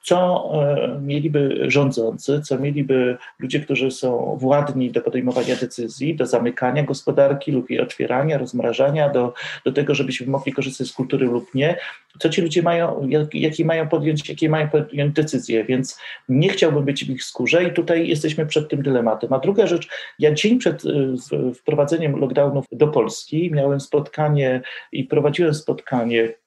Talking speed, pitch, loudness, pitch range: 160 wpm, 140 Hz, -20 LUFS, 130-155 Hz